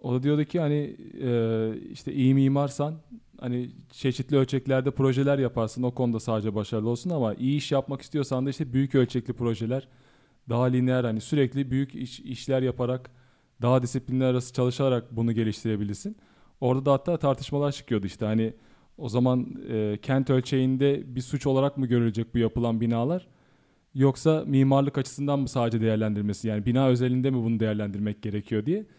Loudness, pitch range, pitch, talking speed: -26 LUFS, 115-135 Hz, 130 Hz, 160 wpm